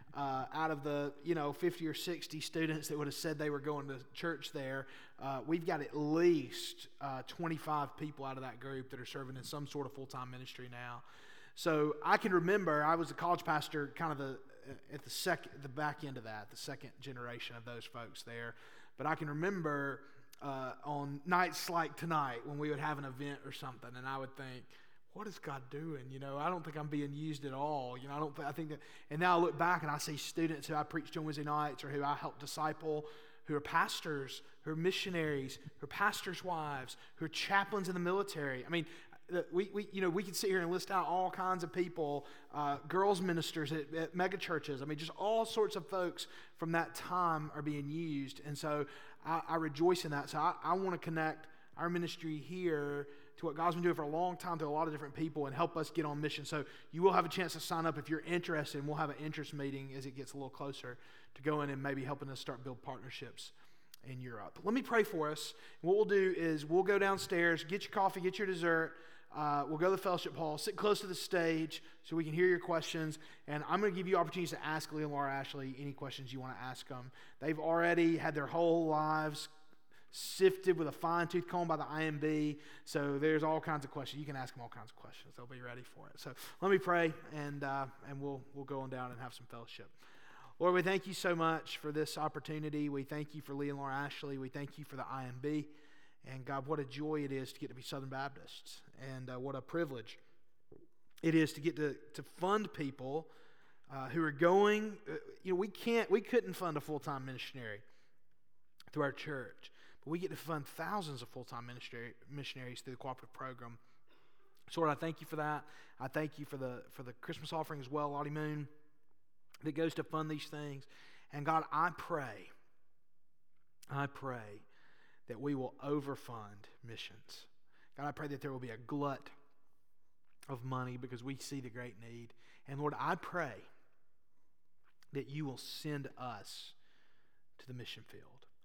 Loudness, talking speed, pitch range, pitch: -38 LUFS, 220 wpm, 135-165 Hz, 150 Hz